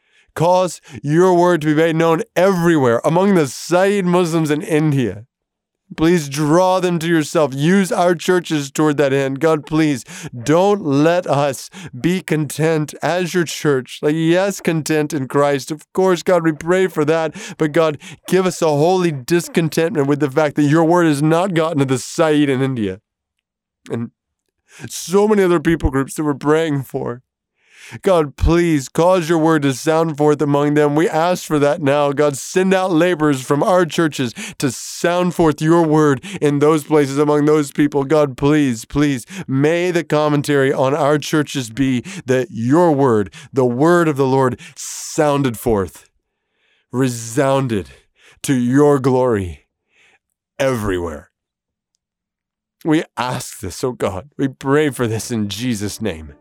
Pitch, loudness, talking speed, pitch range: 150 Hz, -16 LUFS, 155 wpm, 140-170 Hz